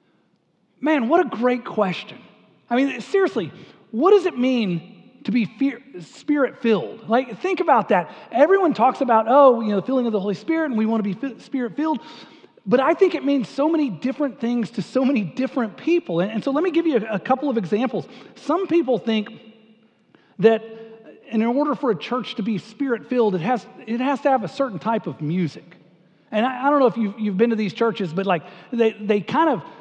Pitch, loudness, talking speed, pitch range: 240 Hz, -21 LUFS, 220 wpm, 220-275 Hz